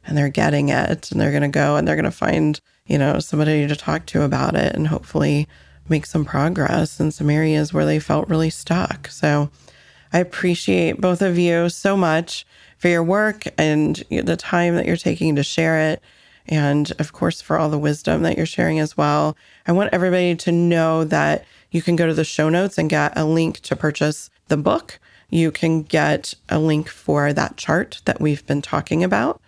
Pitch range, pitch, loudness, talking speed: 145-170 Hz, 155 Hz, -19 LUFS, 205 wpm